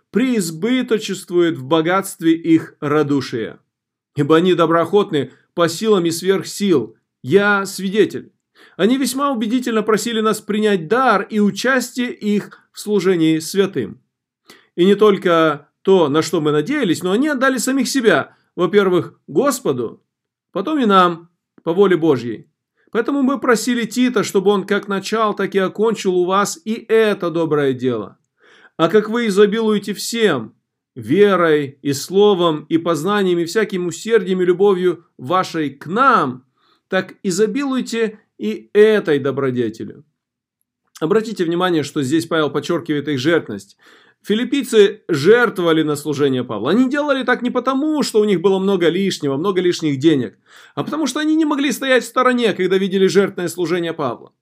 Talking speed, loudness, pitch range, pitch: 145 wpm, -17 LUFS, 165-220 Hz, 190 Hz